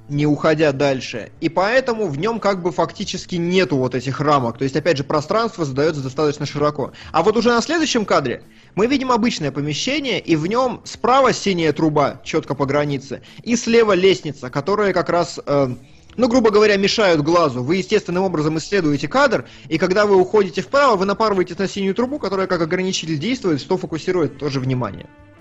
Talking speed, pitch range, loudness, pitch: 180 wpm, 145-205 Hz, -18 LUFS, 175 Hz